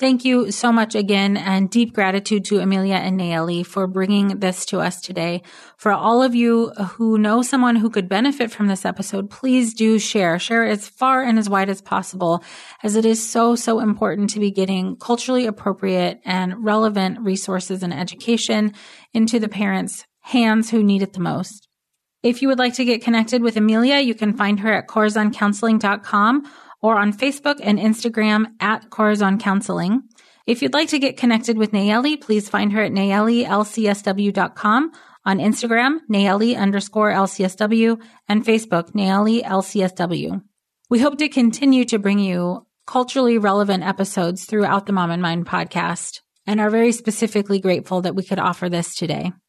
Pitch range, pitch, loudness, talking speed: 195-230 Hz, 210 Hz, -19 LUFS, 170 wpm